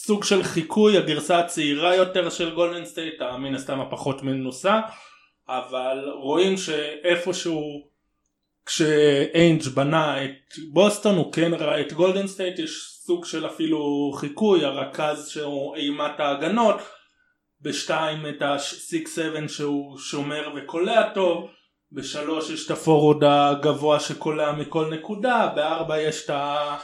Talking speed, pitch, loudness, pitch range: 120 wpm, 155 Hz, -23 LUFS, 145-175 Hz